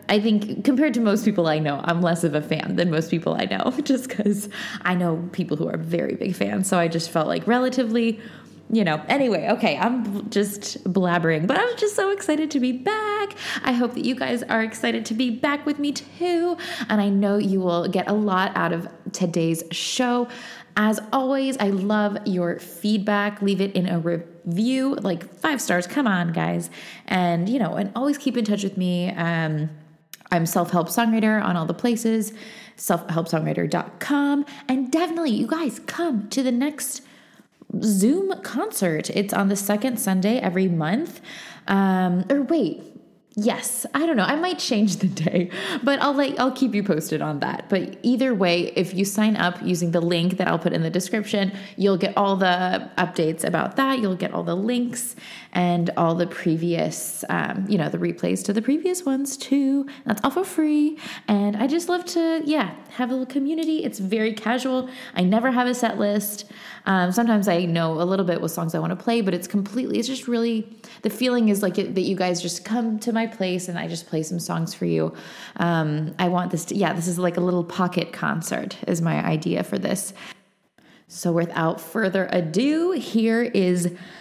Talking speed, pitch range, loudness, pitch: 195 wpm, 175-250 Hz, -23 LUFS, 205 Hz